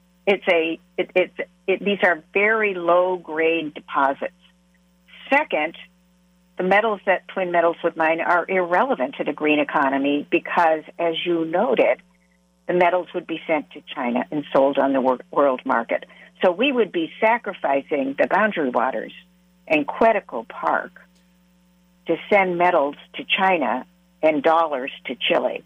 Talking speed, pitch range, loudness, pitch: 145 wpm, 160-185 Hz, -21 LUFS, 180 Hz